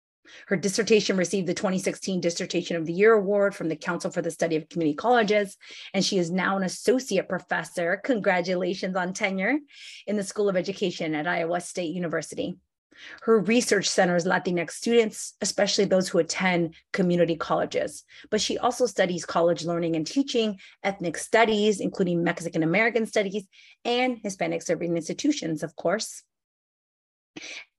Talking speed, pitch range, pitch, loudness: 150 wpm, 170-215 Hz, 190 Hz, -25 LUFS